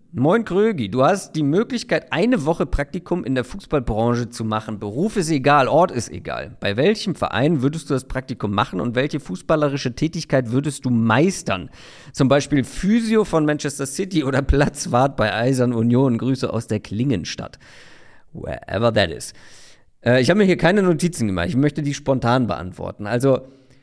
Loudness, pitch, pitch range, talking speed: -20 LUFS, 140 Hz, 120-165 Hz, 170 wpm